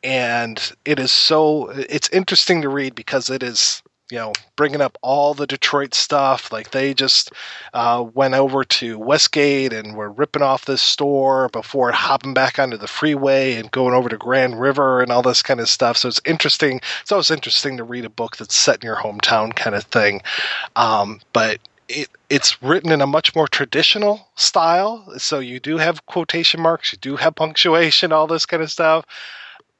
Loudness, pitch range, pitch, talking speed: -17 LUFS, 125-155 Hz, 135 Hz, 190 wpm